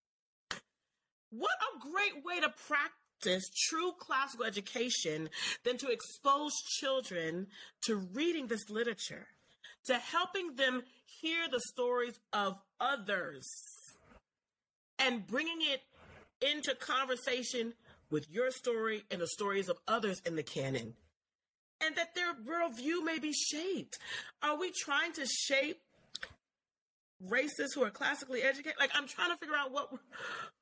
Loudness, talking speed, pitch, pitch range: -35 LUFS, 125 wpm, 260 Hz, 225-305 Hz